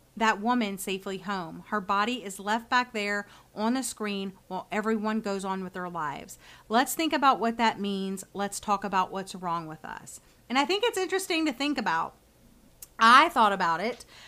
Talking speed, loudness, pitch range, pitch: 190 wpm, -27 LUFS, 195-245 Hz, 210 Hz